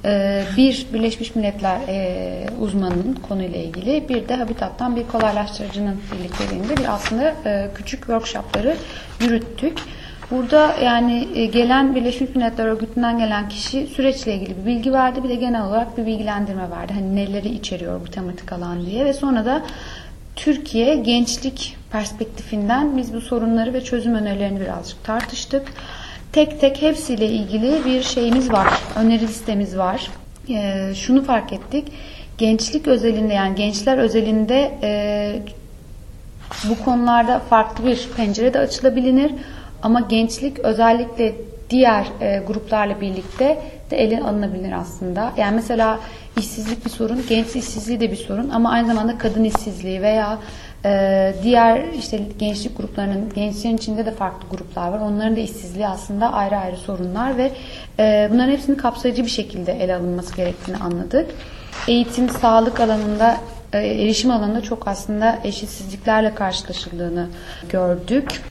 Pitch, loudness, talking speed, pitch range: 225 Hz, -20 LUFS, 135 wpm, 205-245 Hz